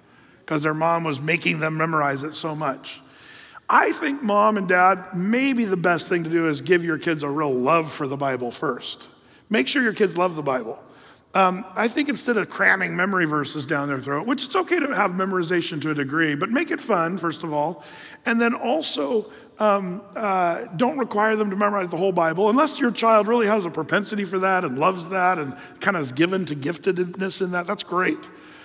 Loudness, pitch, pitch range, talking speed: -22 LUFS, 185 Hz, 160-215 Hz, 215 wpm